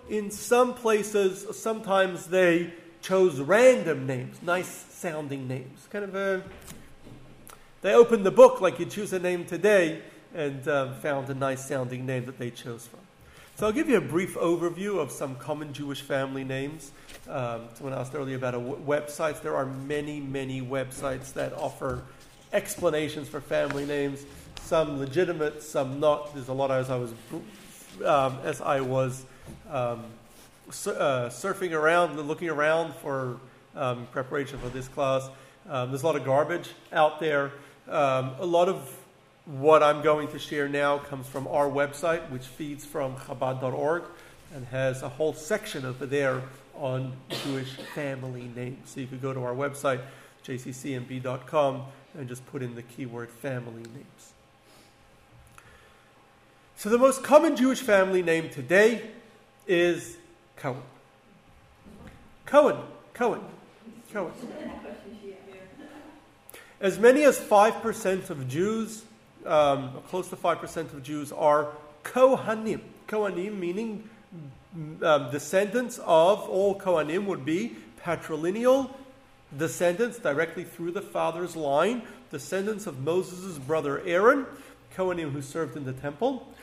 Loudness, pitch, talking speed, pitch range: -27 LUFS, 150 Hz, 140 wpm, 135-185 Hz